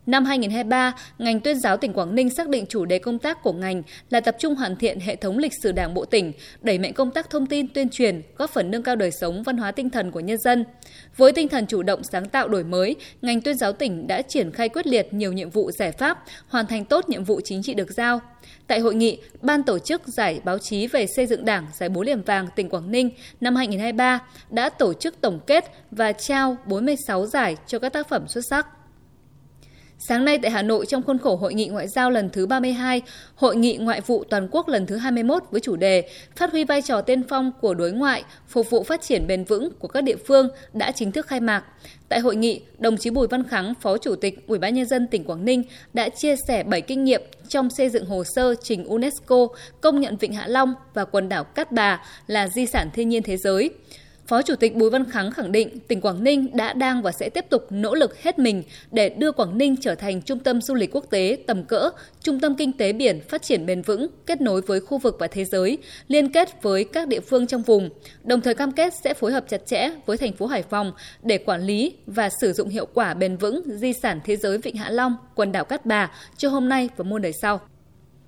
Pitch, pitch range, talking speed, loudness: 235 Hz, 205-265 Hz, 245 wpm, -22 LUFS